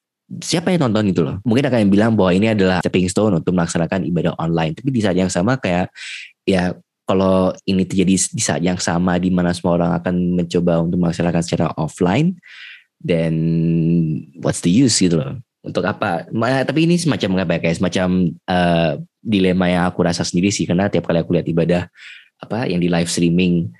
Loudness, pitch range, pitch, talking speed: -17 LUFS, 85-95 Hz, 90 Hz, 190 wpm